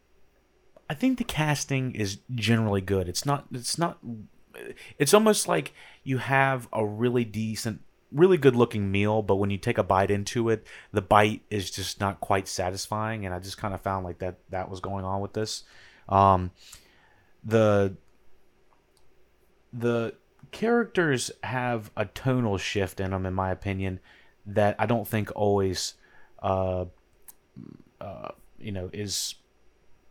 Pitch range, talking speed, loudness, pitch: 95-120 Hz, 145 wpm, -27 LUFS, 105 Hz